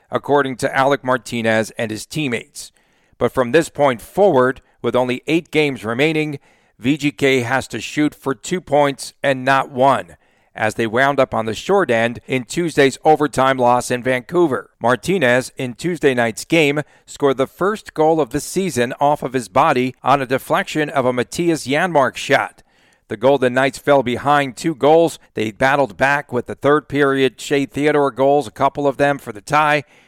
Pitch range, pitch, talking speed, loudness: 125-150 Hz, 135 Hz, 180 wpm, -17 LUFS